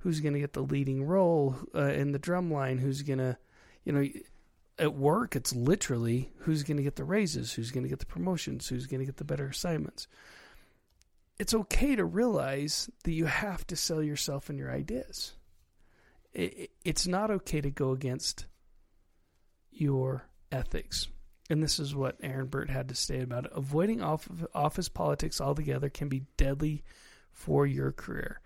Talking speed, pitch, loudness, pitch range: 170 wpm, 140 Hz, -32 LUFS, 125-155 Hz